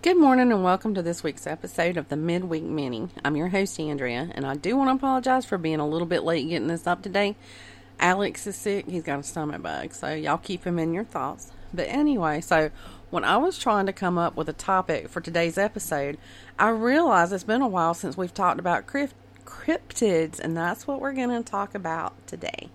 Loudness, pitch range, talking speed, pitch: -26 LUFS, 160-210 Hz, 220 wpm, 175 Hz